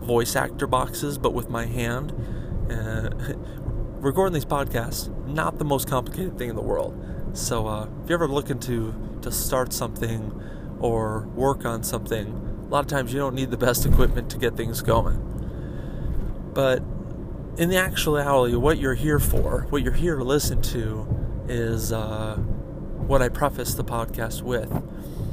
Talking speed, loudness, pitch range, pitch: 160 wpm, -26 LUFS, 110-140 Hz, 120 Hz